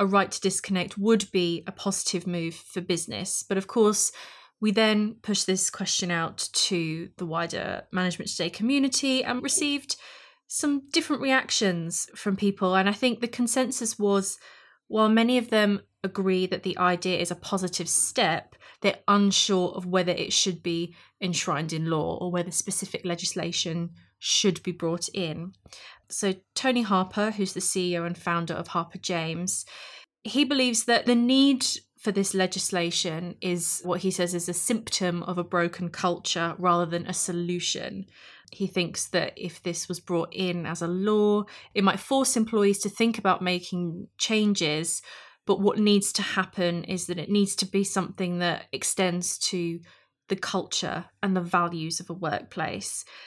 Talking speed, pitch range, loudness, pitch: 165 wpm, 175-205 Hz, -26 LUFS, 185 Hz